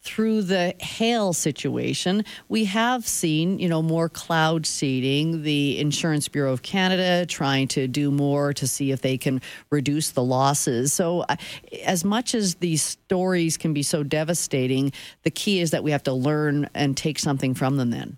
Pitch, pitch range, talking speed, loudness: 155 Hz, 140-180 Hz, 175 wpm, -23 LUFS